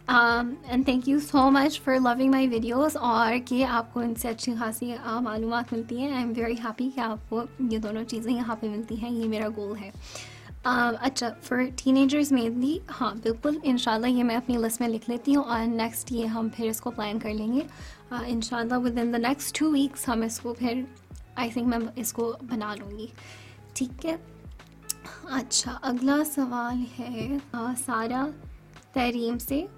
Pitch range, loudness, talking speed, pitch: 230-260 Hz, -27 LUFS, 200 wpm, 240 Hz